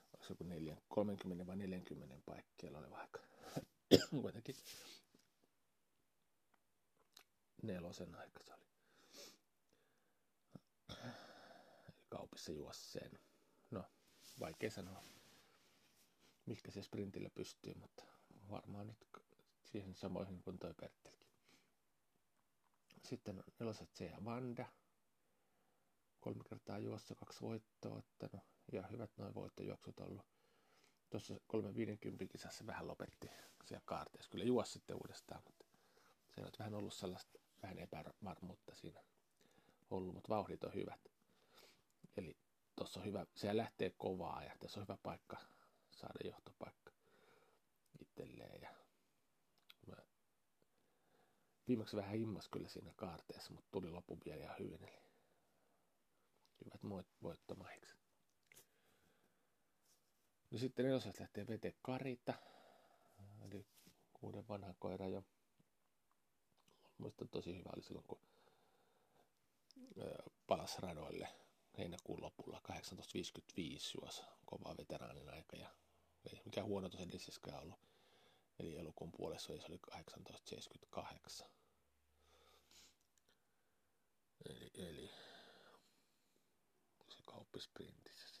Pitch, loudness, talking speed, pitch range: 100 Hz, -49 LUFS, 95 wpm, 90-110 Hz